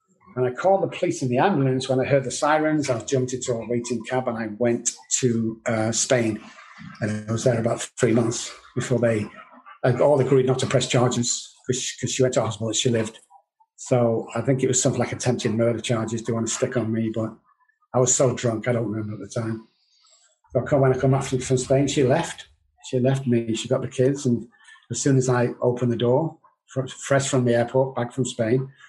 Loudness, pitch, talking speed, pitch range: -23 LUFS, 125 Hz, 220 wpm, 115-130 Hz